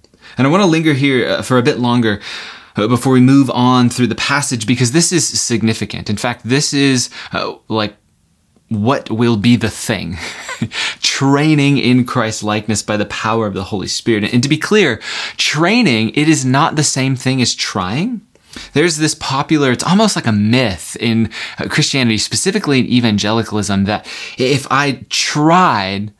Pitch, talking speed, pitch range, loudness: 125 Hz, 165 wpm, 110-140 Hz, -14 LUFS